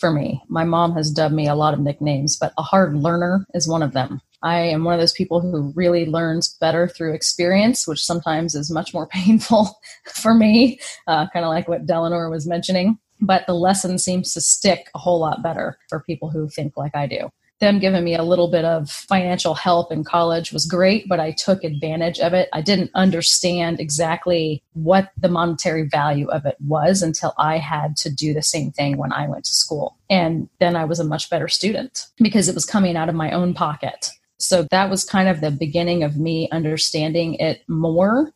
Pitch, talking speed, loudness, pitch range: 170 Hz, 215 wpm, -19 LUFS, 155-180 Hz